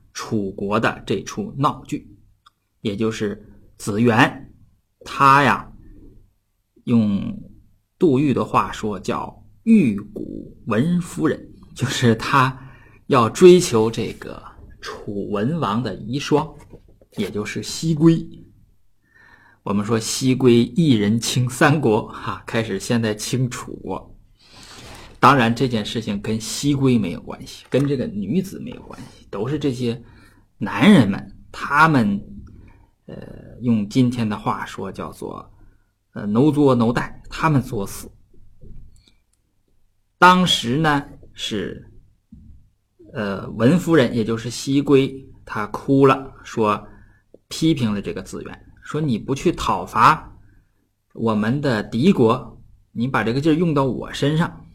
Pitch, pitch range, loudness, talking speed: 115 Hz, 105-135 Hz, -19 LUFS, 170 characters per minute